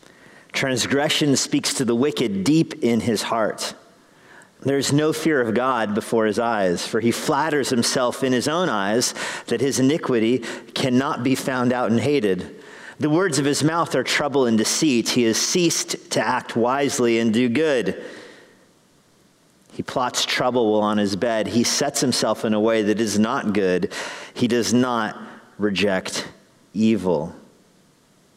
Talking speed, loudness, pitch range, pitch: 160 wpm, -21 LUFS, 110-140 Hz, 120 Hz